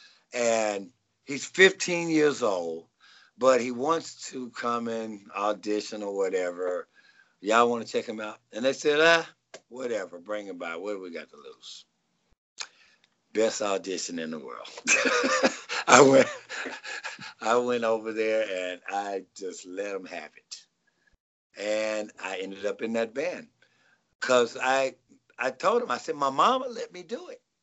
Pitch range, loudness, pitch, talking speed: 105-150 Hz, -27 LUFS, 115 Hz, 155 wpm